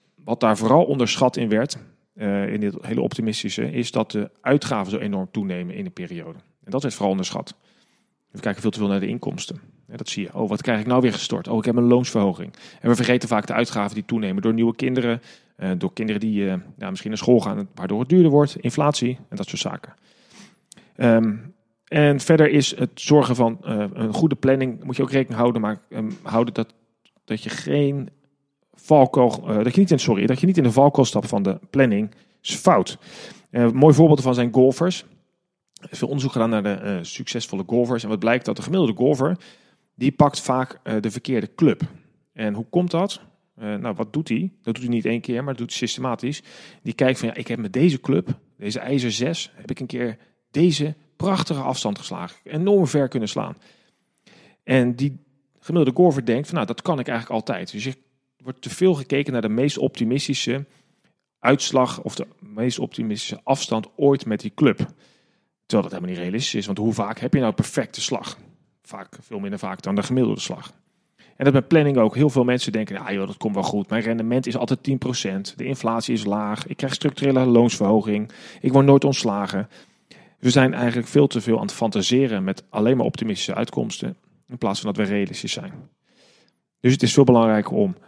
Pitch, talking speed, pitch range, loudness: 125 Hz, 210 wpm, 110-145 Hz, -21 LUFS